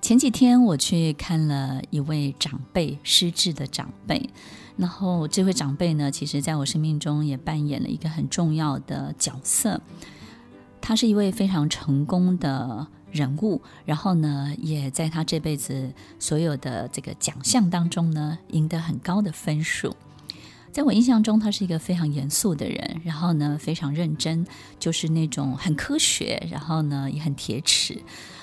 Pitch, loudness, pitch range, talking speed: 155 Hz, -24 LUFS, 145-175 Hz, 245 characters per minute